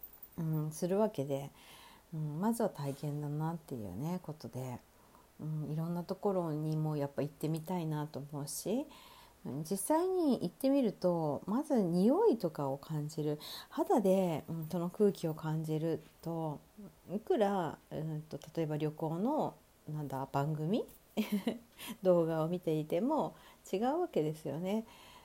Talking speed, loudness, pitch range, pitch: 270 characters per minute, -36 LUFS, 150-200 Hz, 160 Hz